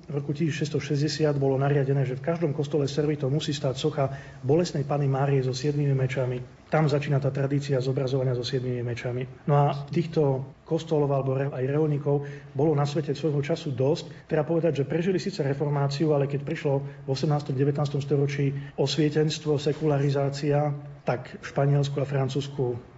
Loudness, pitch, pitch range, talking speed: -26 LUFS, 145 Hz, 135-150 Hz, 160 wpm